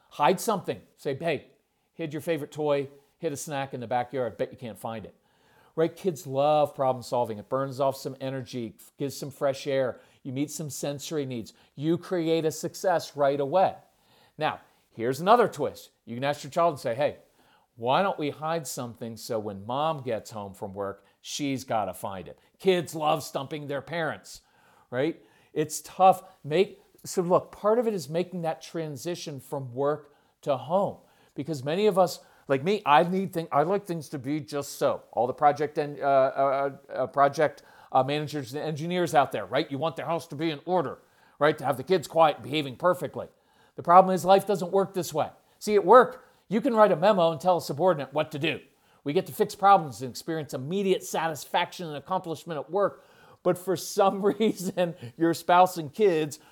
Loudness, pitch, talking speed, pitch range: -27 LUFS, 155 Hz, 200 wpm, 140-180 Hz